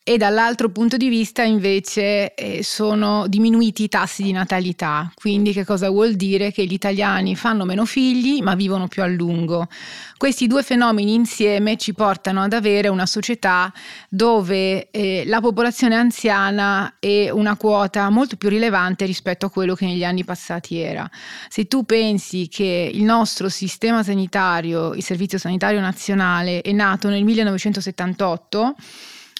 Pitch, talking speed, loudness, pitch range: 200 Hz, 150 wpm, -19 LUFS, 190-220 Hz